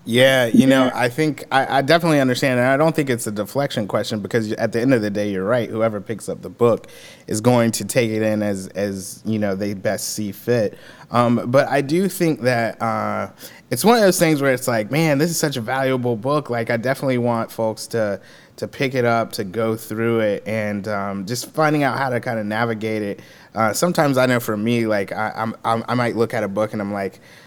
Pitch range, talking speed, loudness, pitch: 110-135 Hz, 240 wpm, -20 LUFS, 115 Hz